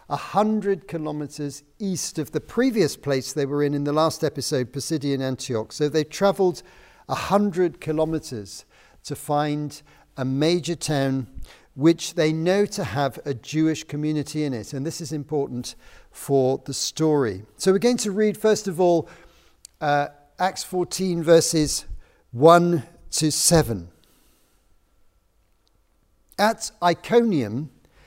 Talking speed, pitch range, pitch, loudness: 135 wpm, 135-170 Hz, 150 Hz, -23 LUFS